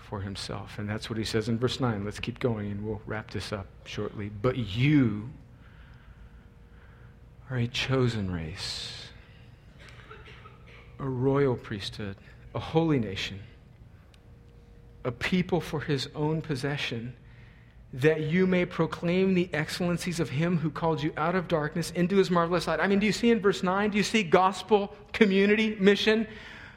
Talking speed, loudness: 155 wpm, -28 LUFS